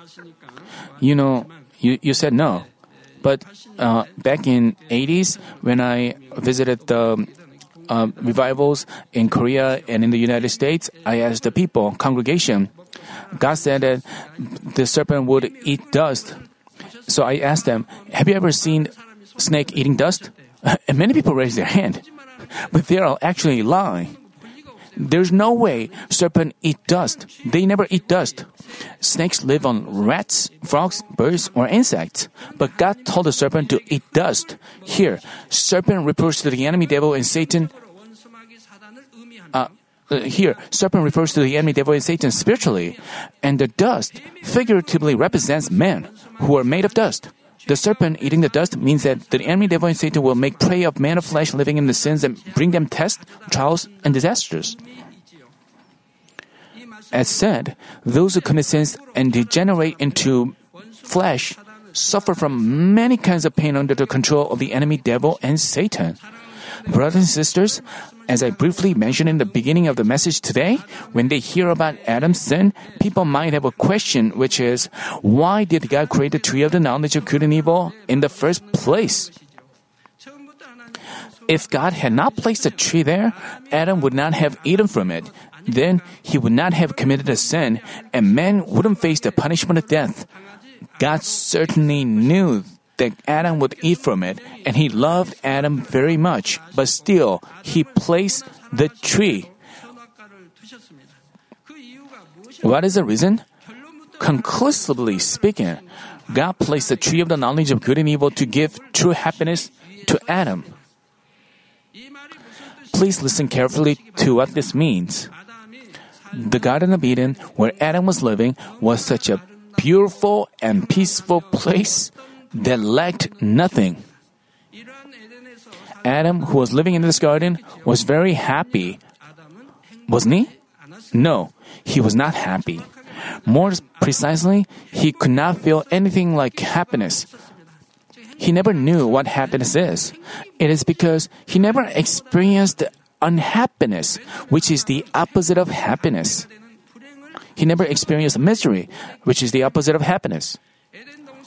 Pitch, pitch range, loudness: 165 Hz, 140-200 Hz, -18 LUFS